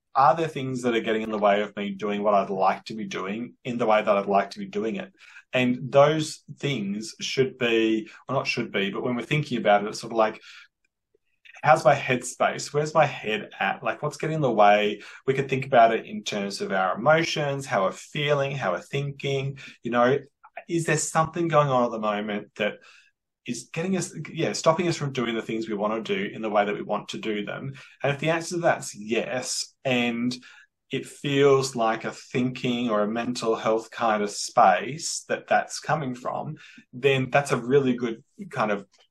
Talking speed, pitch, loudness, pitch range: 220 wpm, 125 Hz, -25 LUFS, 110-145 Hz